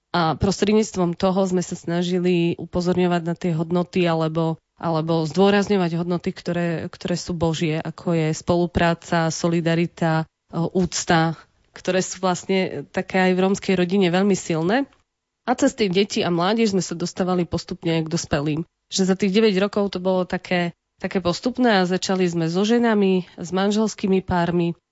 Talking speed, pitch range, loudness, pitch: 150 wpm, 170-190 Hz, -21 LUFS, 180 Hz